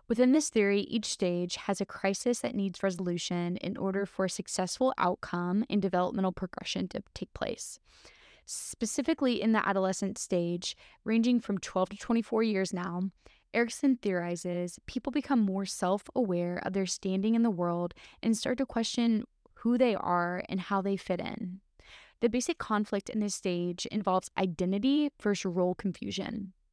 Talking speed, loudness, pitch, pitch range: 160 wpm, -31 LUFS, 200 Hz, 185-230 Hz